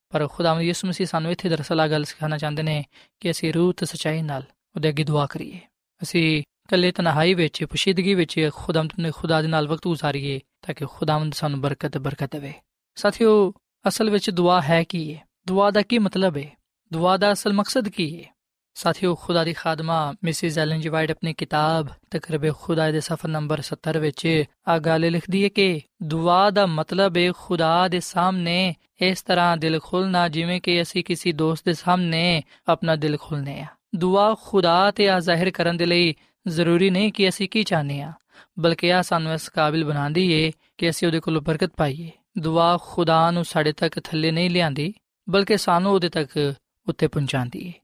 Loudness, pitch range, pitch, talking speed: -22 LUFS, 155-180 Hz, 170 Hz, 185 wpm